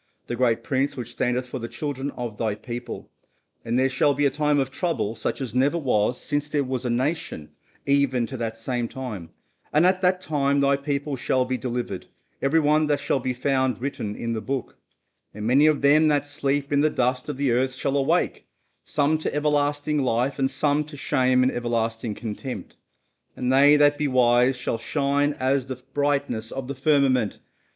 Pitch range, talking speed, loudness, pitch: 125-145 Hz, 195 wpm, -24 LUFS, 135 Hz